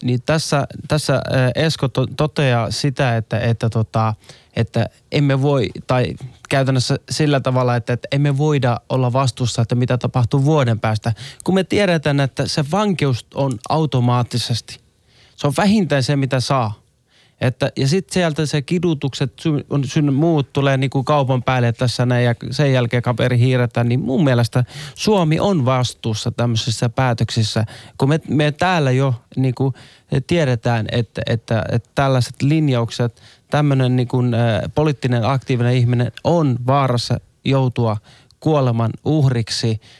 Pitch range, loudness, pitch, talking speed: 120-145 Hz, -18 LUFS, 130 Hz, 135 wpm